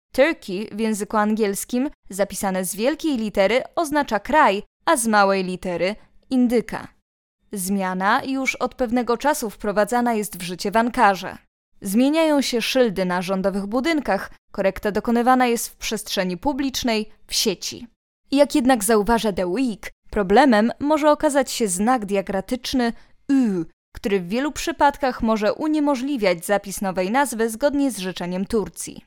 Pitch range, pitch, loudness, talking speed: 195-265 Hz, 225 Hz, -21 LUFS, 135 wpm